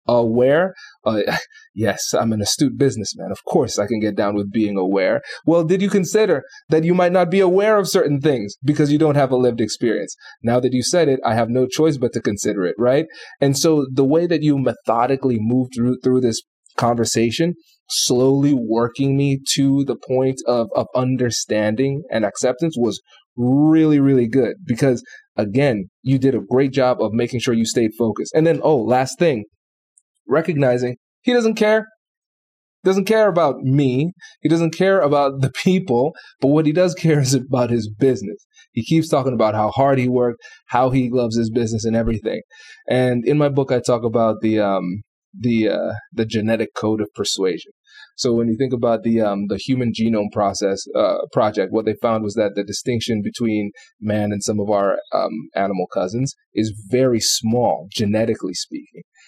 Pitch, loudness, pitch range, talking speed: 125 Hz, -18 LUFS, 115-150 Hz, 185 wpm